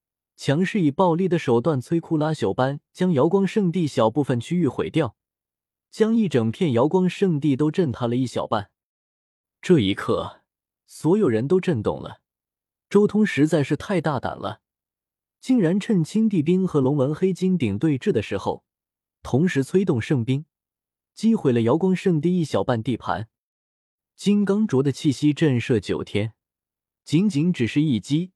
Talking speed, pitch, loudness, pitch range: 235 characters per minute, 155 Hz, -22 LUFS, 125-185 Hz